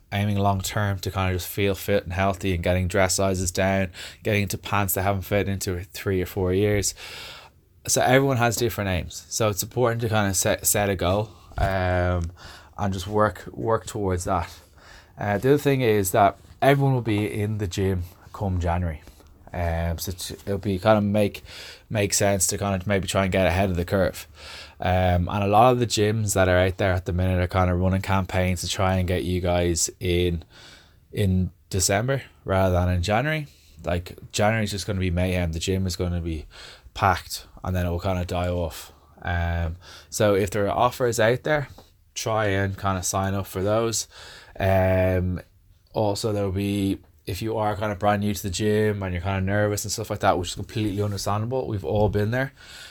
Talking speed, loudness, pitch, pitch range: 210 wpm, -24 LUFS, 95 Hz, 90-105 Hz